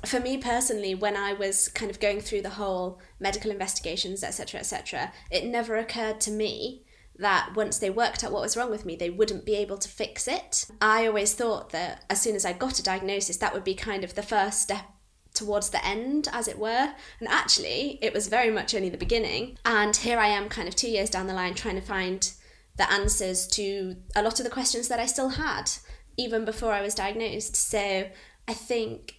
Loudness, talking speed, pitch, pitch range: -27 LUFS, 220 wpm, 210 Hz, 195-225 Hz